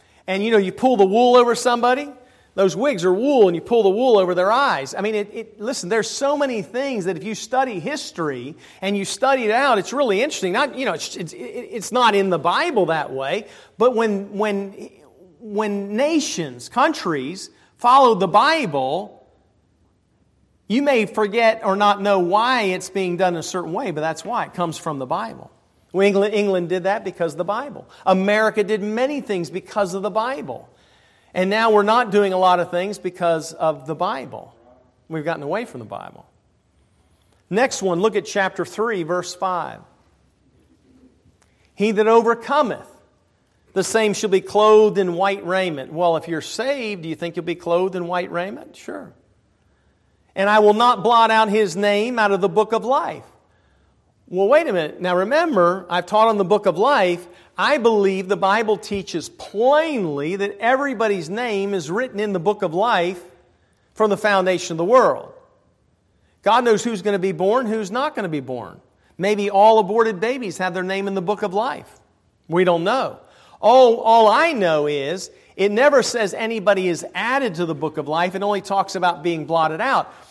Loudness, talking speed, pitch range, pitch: -19 LUFS, 190 wpm, 180-225 Hz, 200 Hz